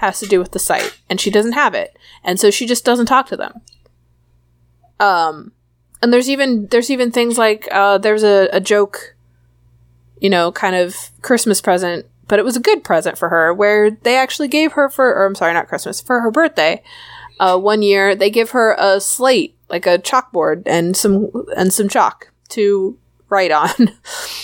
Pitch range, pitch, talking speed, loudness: 180-245 Hz, 205 Hz, 195 wpm, -15 LUFS